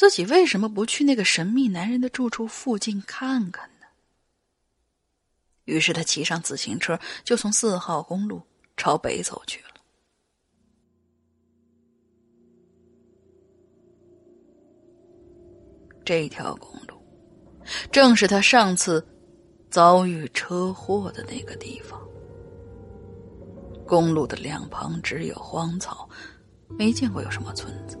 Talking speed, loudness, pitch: 160 characters per minute, -23 LUFS, 175 Hz